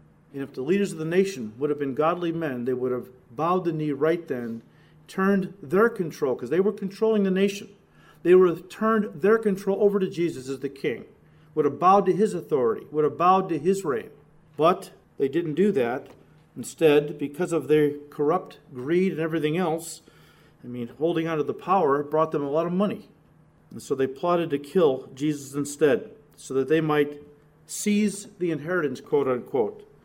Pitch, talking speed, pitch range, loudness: 160 Hz, 190 wpm, 150-190 Hz, -25 LUFS